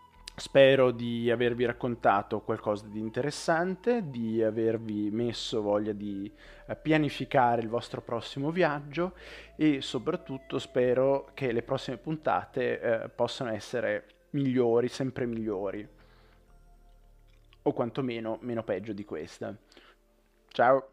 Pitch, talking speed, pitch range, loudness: 120 Hz, 105 wpm, 110-135 Hz, -30 LUFS